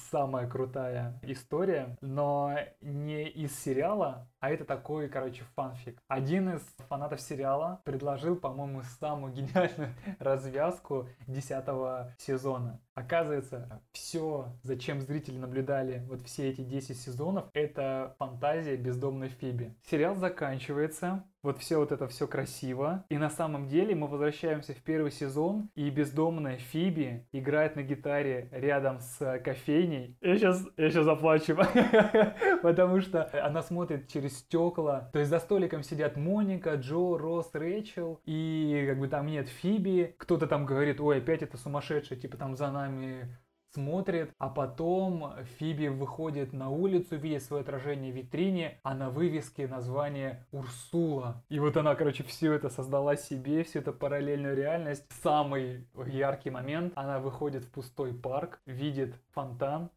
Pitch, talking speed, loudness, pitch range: 145 Hz, 140 wpm, -32 LUFS, 135-160 Hz